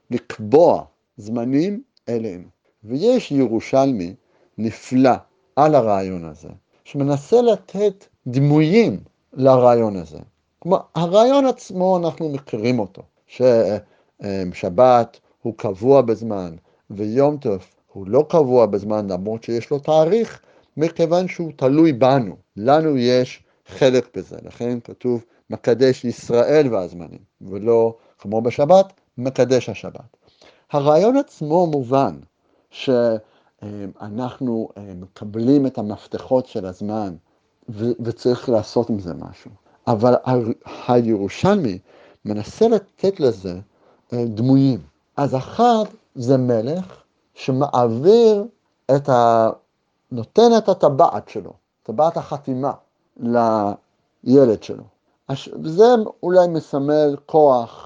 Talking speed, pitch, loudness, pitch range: 95 wpm, 125 Hz, -18 LUFS, 110-150 Hz